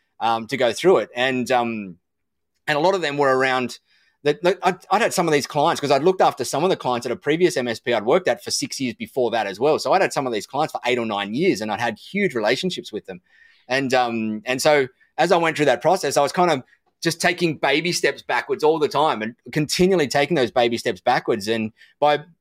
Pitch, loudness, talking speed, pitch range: 145 Hz, -21 LUFS, 255 wpm, 125-175 Hz